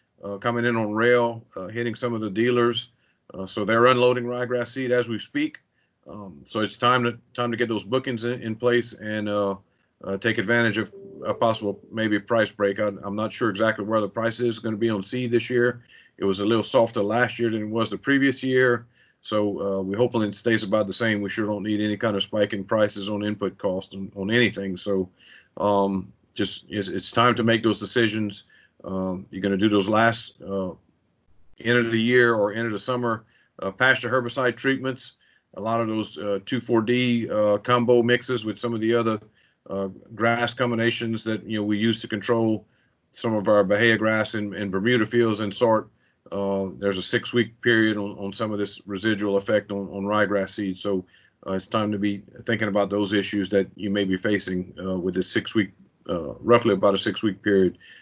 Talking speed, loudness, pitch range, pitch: 210 wpm, -24 LUFS, 100-120 Hz, 110 Hz